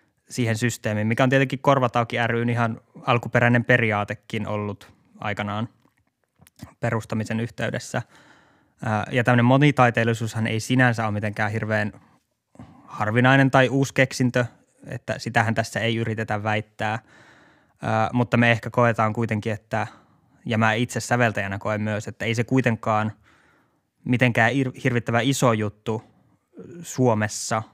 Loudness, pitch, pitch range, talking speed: -22 LUFS, 115 Hz, 110-125 Hz, 115 wpm